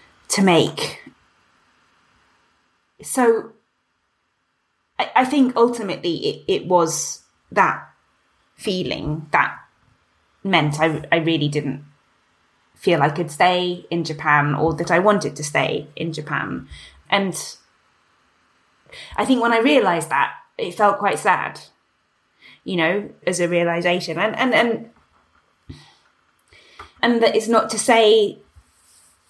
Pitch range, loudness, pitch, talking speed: 160-220 Hz, -19 LUFS, 175 Hz, 115 wpm